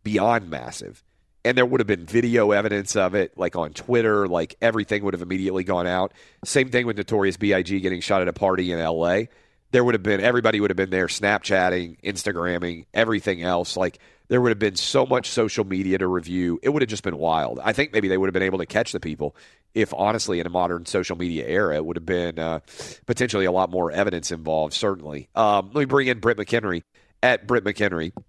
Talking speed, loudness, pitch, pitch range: 225 wpm, -23 LUFS, 95 Hz, 85-105 Hz